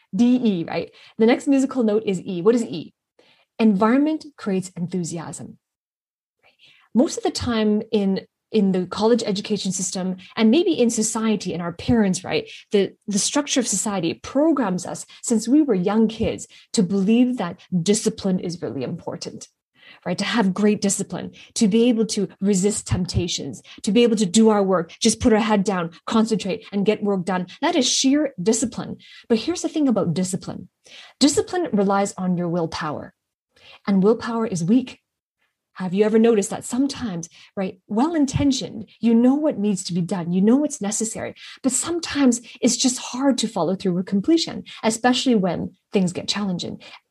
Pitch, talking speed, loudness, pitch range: 215 Hz, 170 wpm, -21 LUFS, 190-245 Hz